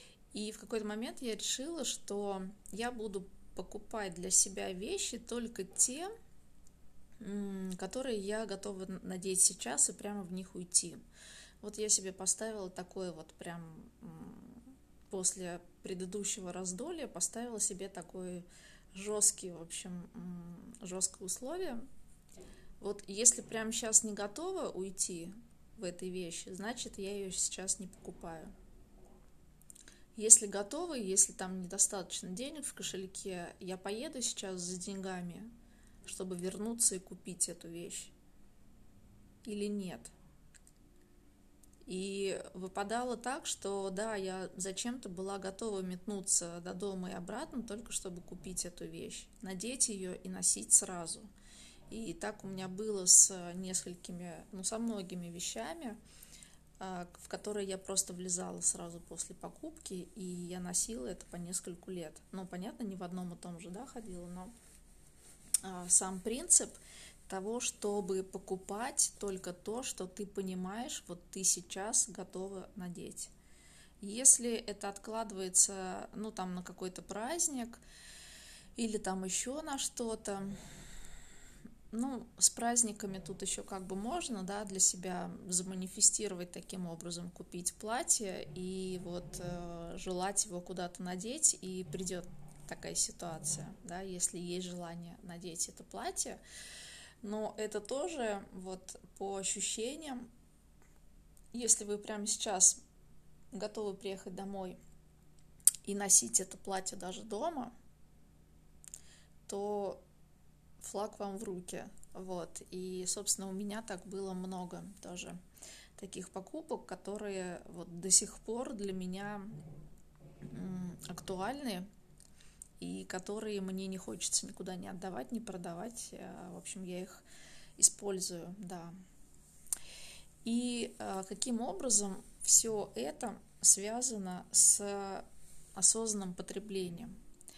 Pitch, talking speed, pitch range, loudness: 195 Hz, 120 wpm, 185-215 Hz, -34 LUFS